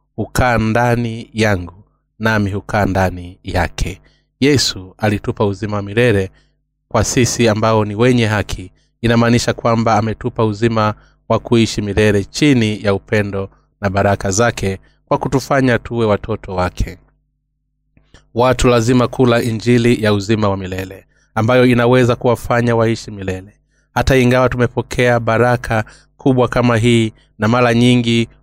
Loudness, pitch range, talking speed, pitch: -15 LUFS, 100-120 Hz, 125 wpm, 115 Hz